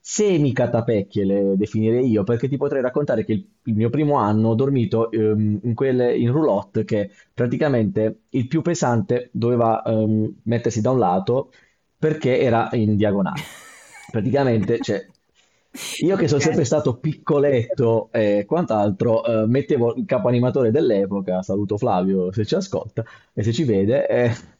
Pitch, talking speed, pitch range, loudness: 115 Hz, 150 wpm, 110-130 Hz, -20 LUFS